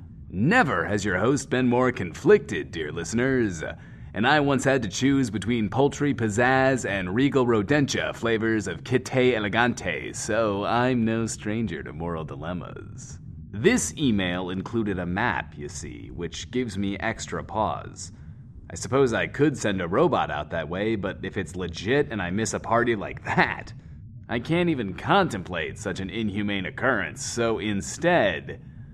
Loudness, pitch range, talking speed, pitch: -25 LUFS, 95-125 Hz, 155 wpm, 110 Hz